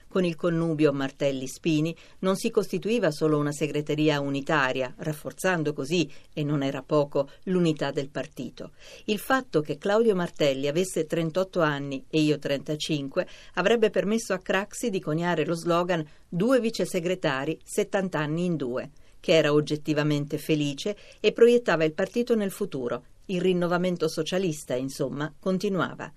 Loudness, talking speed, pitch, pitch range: -26 LUFS, 140 wpm, 160 Hz, 150-190 Hz